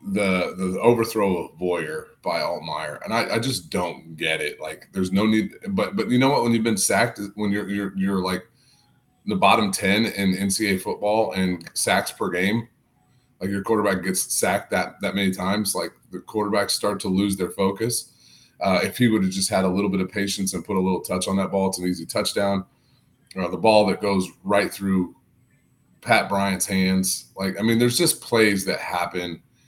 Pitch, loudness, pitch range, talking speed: 100 Hz, -23 LUFS, 95-110 Hz, 205 wpm